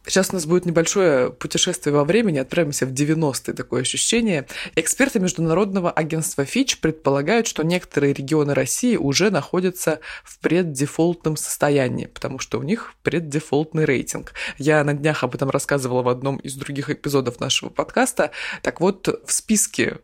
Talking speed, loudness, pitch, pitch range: 150 wpm, -21 LUFS, 155 Hz, 140-180 Hz